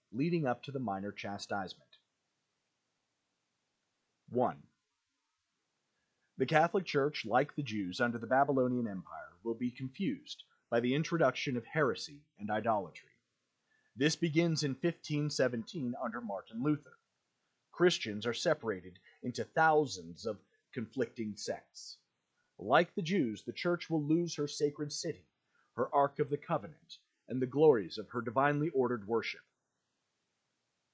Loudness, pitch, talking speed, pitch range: -34 LUFS, 140 Hz, 125 wpm, 115-155 Hz